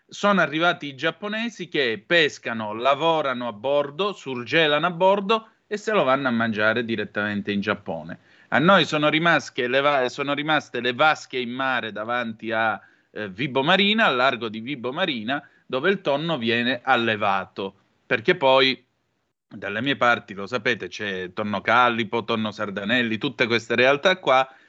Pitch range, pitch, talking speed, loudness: 115-160 Hz, 130 Hz, 150 wpm, -22 LUFS